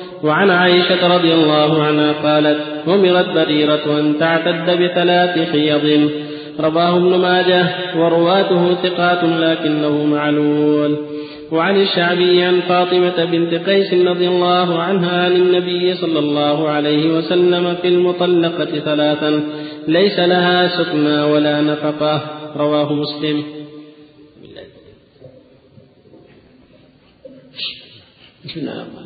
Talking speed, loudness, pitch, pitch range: 95 wpm, -15 LUFS, 165 Hz, 150-180 Hz